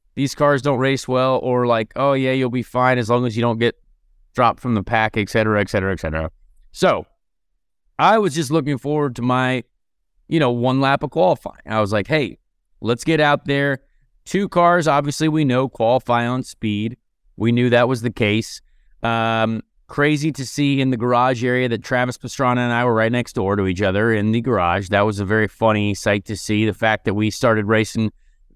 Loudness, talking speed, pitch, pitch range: -19 LUFS, 210 wpm, 120 Hz, 110-135 Hz